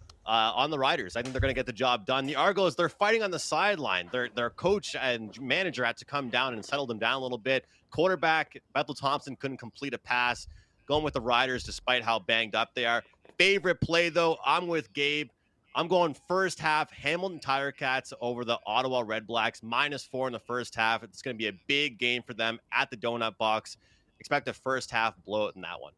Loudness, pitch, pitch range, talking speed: -29 LUFS, 125 Hz, 115-145 Hz, 225 wpm